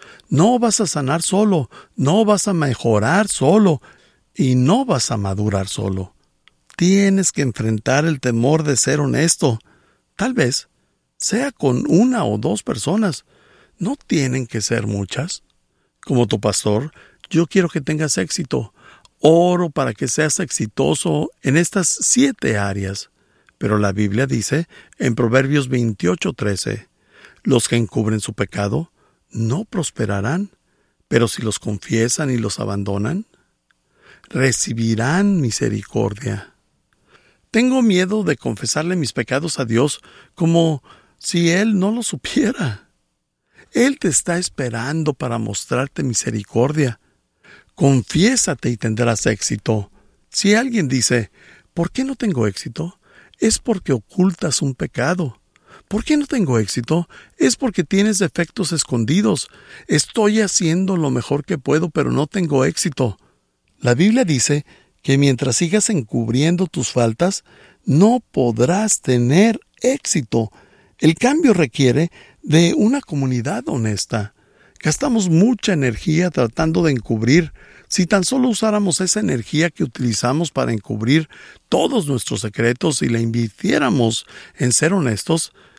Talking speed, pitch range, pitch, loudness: 125 wpm, 115-185 Hz, 145 Hz, -18 LUFS